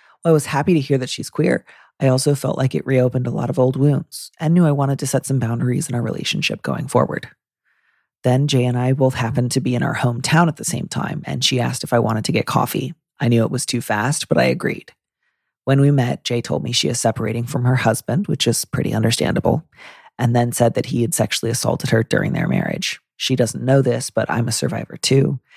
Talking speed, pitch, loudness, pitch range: 240 wpm, 130 Hz, -19 LUFS, 120-140 Hz